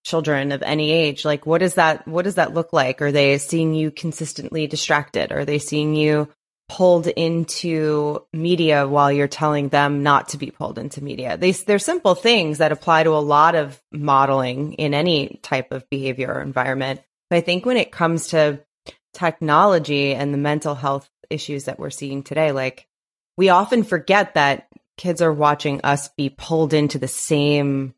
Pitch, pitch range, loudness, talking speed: 150 Hz, 140-165 Hz, -19 LUFS, 180 wpm